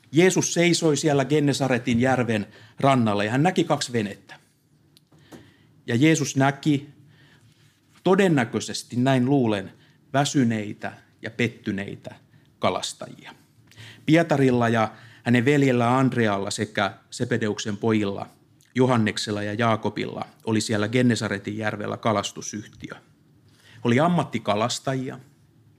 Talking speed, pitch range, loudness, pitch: 90 wpm, 110-140 Hz, -23 LUFS, 120 Hz